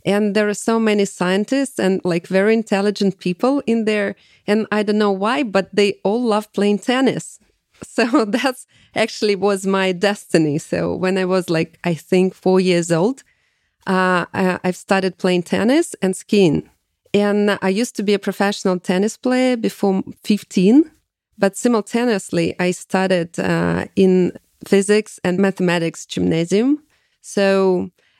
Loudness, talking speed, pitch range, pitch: -18 LUFS, 150 wpm, 185-215 Hz, 195 Hz